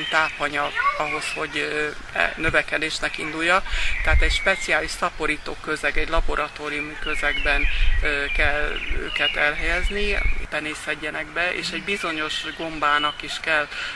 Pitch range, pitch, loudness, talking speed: 150-165 Hz, 155 Hz, -23 LUFS, 105 wpm